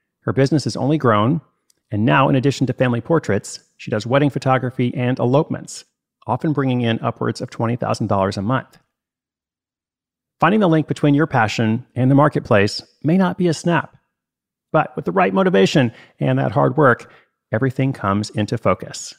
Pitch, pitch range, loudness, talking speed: 130 Hz, 115-150 Hz, -18 LUFS, 165 wpm